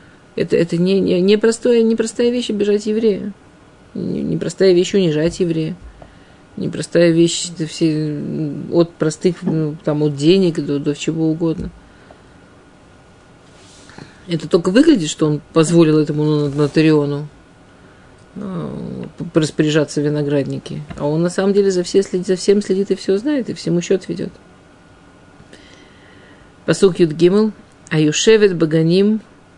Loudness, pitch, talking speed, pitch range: -16 LUFS, 170 Hz, 120 wpm, 150-195 Hz